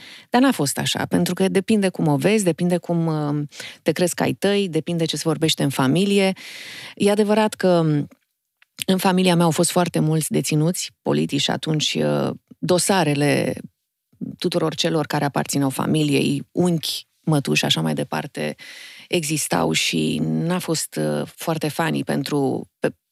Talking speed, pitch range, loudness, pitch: 145 wpm, 140-180 Hz, -21 LUFS, 160 Hz